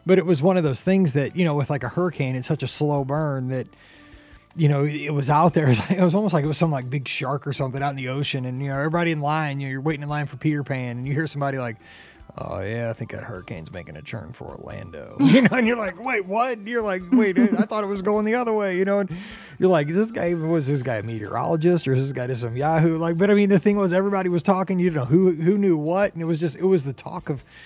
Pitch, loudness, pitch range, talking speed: 160 Hz, -22 LUFS, 140-190 Hz, 305 wpm